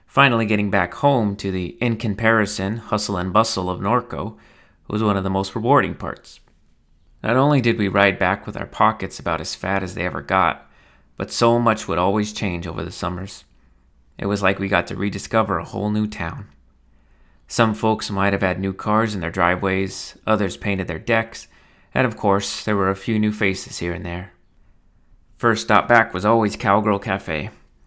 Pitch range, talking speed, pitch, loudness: 90-110 Hz, 190 wpm, 100 Hz, -20 LUFS